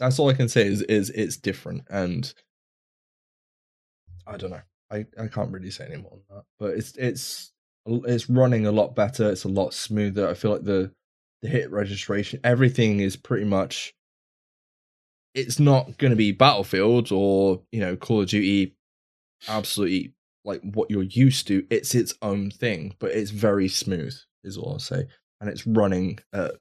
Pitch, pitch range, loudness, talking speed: 105 Hz, 95-120 Hz, -24 LUFS, 180 wpm